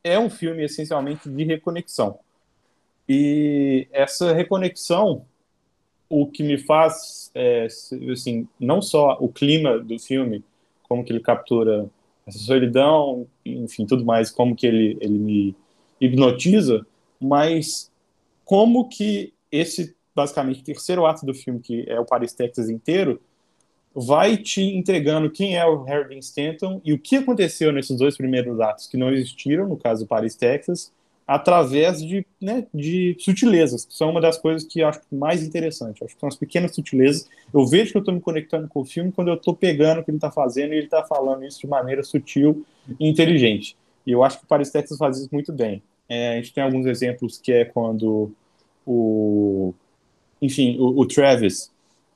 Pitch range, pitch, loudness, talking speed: 125-165 Hz, 145 Hz, -21 LUFS, 175 wpm